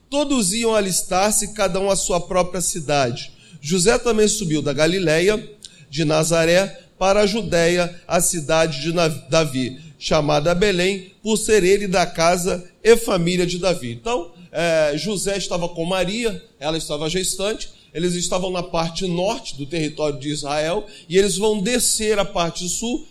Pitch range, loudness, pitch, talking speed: 160-200 Hz, -20 LUFS, 180 Hz, 150 wpm